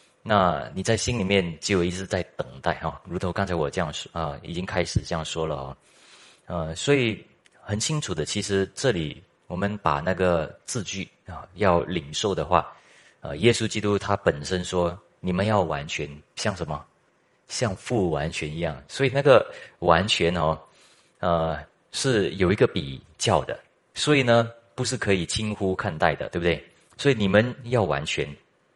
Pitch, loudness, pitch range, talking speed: 90 Hz, -25 LUFS, 80-105 Hz, 250 characters per minute